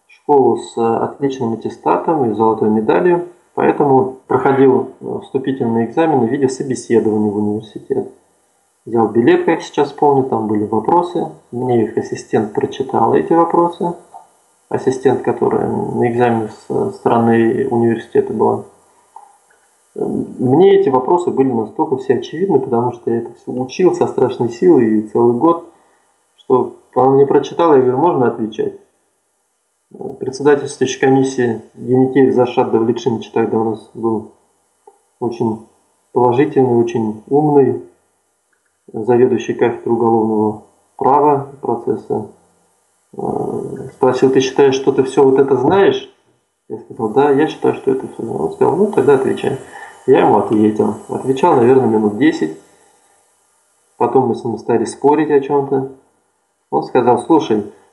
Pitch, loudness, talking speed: 135 Hz, -15 LUFS, 130 wpm